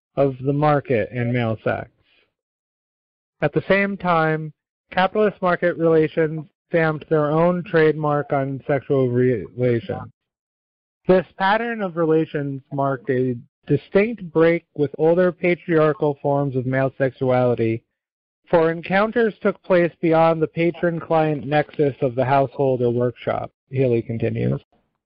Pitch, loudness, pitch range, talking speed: 150 Hz, -20 LUFS, 135-170 Hz, 120 wpm